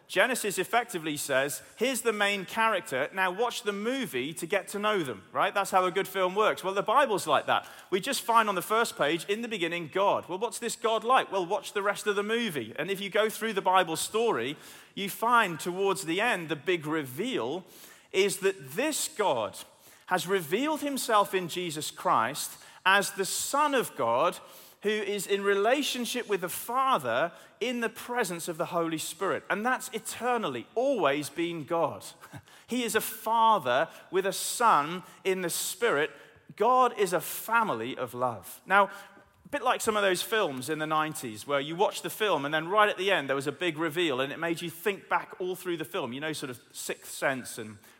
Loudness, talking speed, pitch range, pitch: -29 LUFS, 205 wpm, 170-225 Hz, 195 Hz